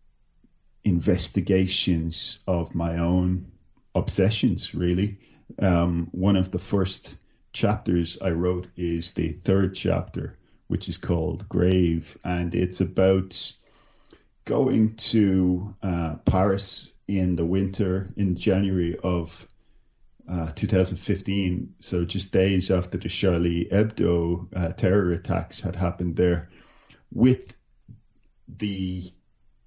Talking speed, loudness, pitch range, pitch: 105 wpm, -25 LUFS, 85-95 Hz, 90 Hz